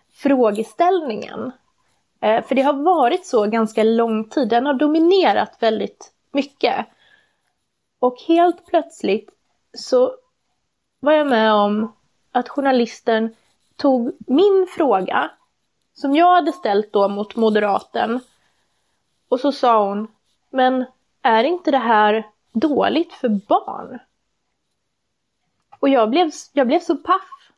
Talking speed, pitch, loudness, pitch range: 120 wpm, 265 Hz, -18 LUFS, 225-335 Hz